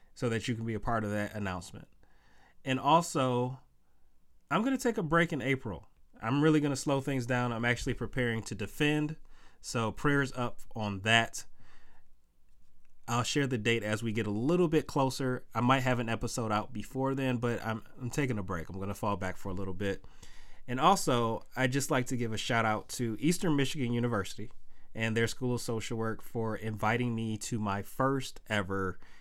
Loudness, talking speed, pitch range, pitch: -32 LUFS, 195 wpm, 105-130 Hz, 120 Hz